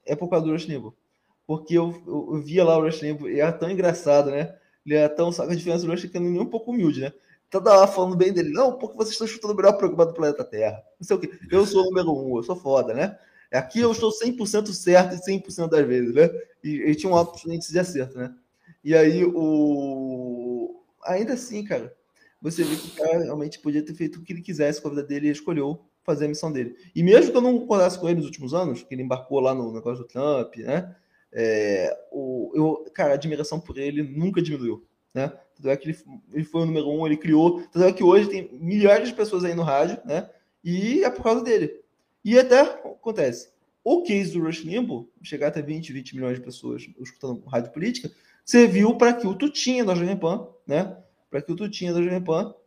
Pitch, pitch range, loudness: 165 Hz, 145-190 Hz, -23 LUFS